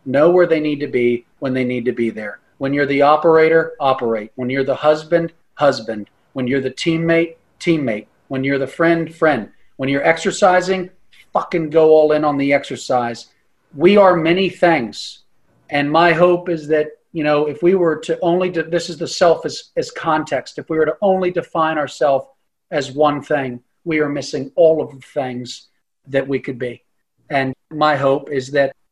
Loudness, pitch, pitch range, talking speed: -17 LUFS, 150 Hz, 135-165 Hz, 190 wpm